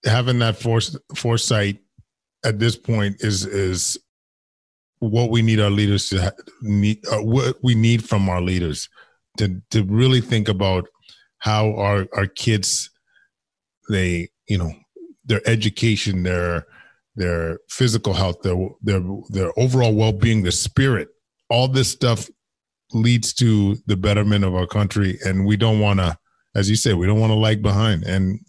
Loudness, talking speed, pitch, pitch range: -20 LUFS, 160 wpm, 105 Hz, 95-115 Hz